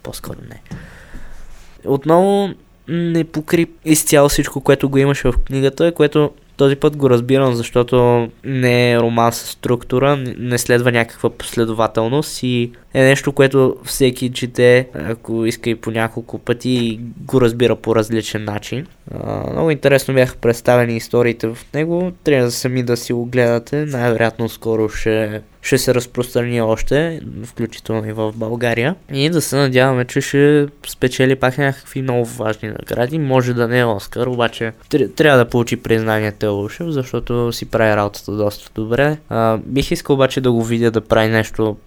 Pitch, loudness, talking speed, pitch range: 125 Hz, -16 LUFS, 155 wpm, 115-140 Hz